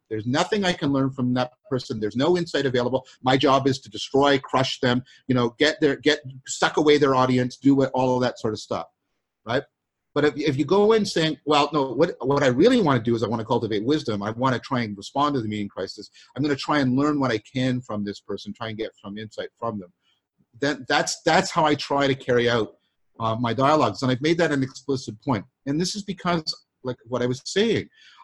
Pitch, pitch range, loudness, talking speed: 130 Hz, 120-150 Hz, -23 LUFS, 250 wpm